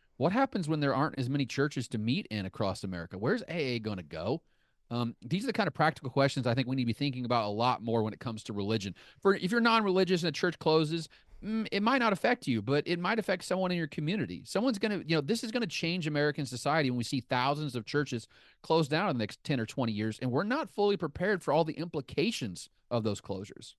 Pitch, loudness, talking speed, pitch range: 145 Hz, -31 LUFS, 255 wpm, 120-185 Hz